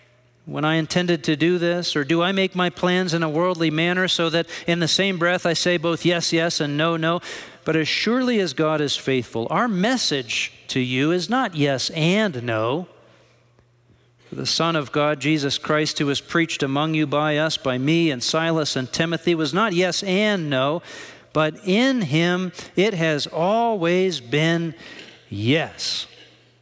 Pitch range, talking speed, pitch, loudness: 145-180 Hz, 180 wpm, 165 Hz, -21 LUFS